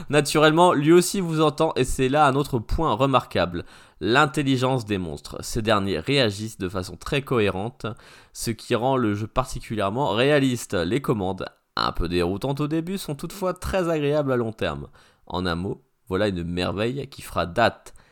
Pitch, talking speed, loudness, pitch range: 130 Hz, 170 wpm, -23 LUFS, 100-150 Hz